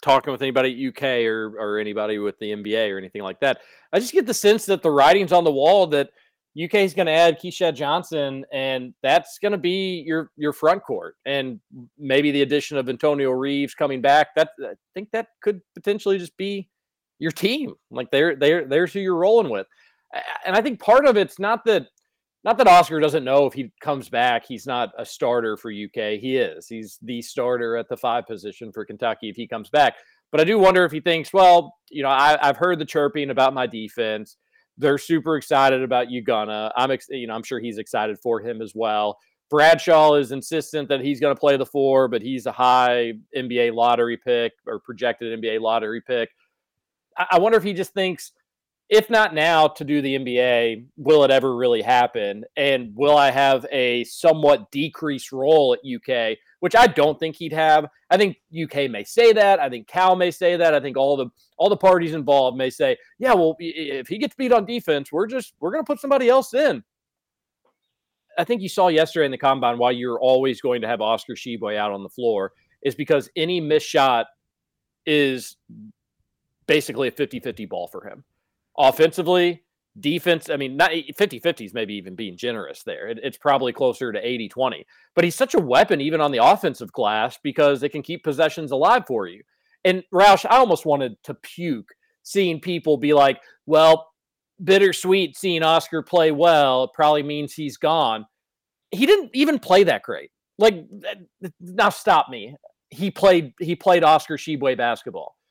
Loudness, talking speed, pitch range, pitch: -20 LUFS, 195 wpm, 130-185 Hz, 150 Hz